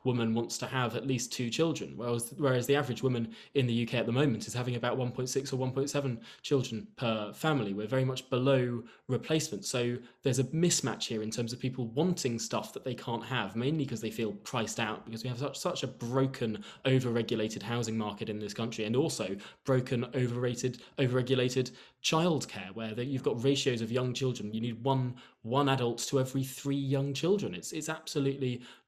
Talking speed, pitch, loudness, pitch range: 195 wpm, 125 Hz, -32 LUFS, 115-135 Hz